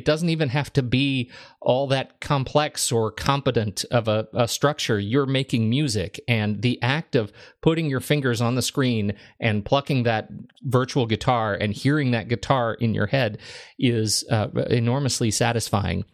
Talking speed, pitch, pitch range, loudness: 165 wpm, 125 Hz, 110-140 Hz, -23 LUFS